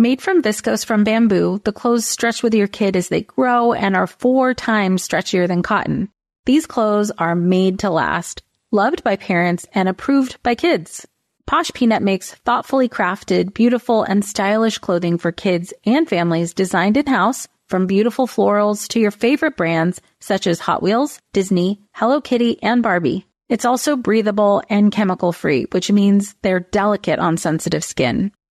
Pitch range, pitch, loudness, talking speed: 185-235 Hz, 210 Hz, -17 LUFS, 165 wpm